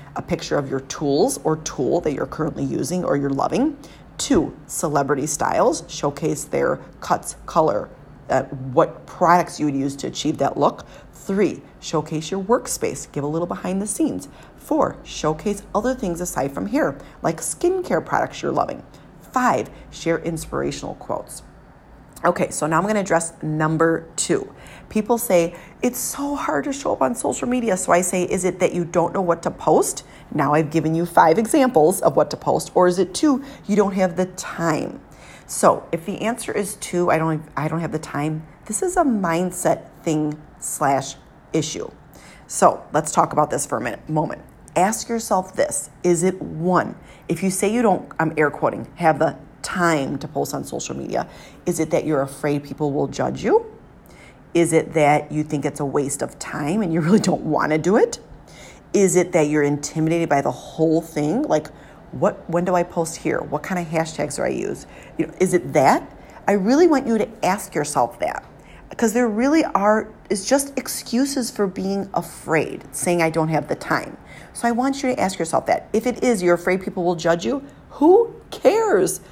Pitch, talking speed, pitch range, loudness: 175 Hz, 195 wpm, 155-210 Hz, -21 LUFS